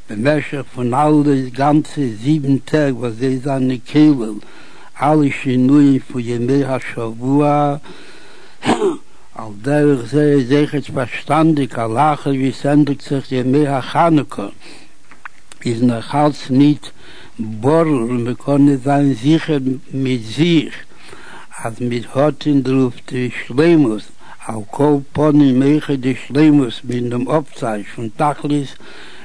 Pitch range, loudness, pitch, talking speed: 125-150 Hz, -16 LUFS, 140 Hz, 120 wpm